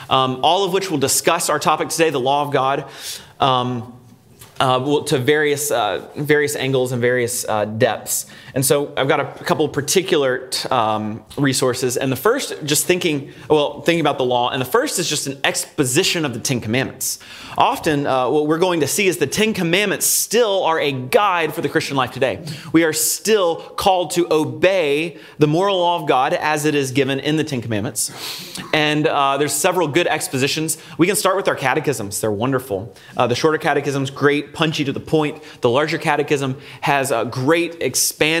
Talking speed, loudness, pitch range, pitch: 195 wpm, -18 LUFS, 130-165 Hz, 150 Hz